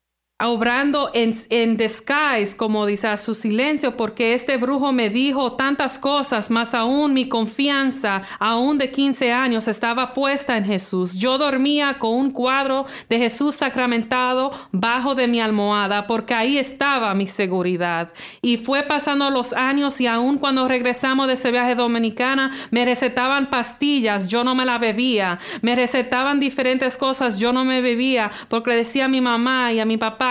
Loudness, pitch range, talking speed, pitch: -19 LUFS, 225-270 Hz, 165 wpm, 250 Hz